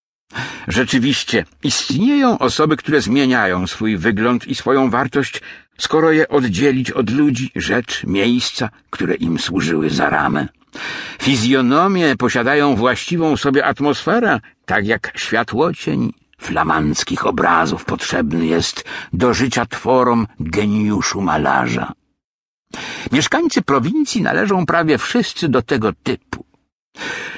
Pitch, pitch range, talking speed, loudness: 130 Hz, 115-155 Hz, 105 wpm, -17 LUFS